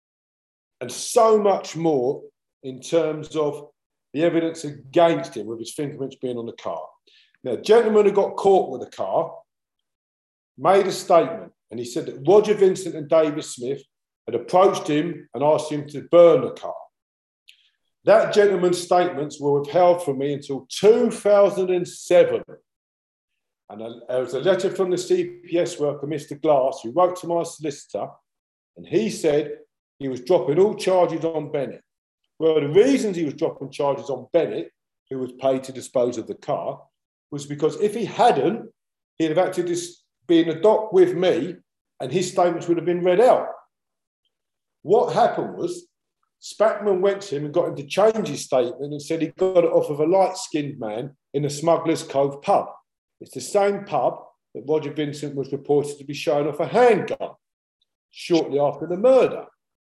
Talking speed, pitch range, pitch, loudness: 170 wpm, 145-190 Hz, 165 Hz, -21 LUFS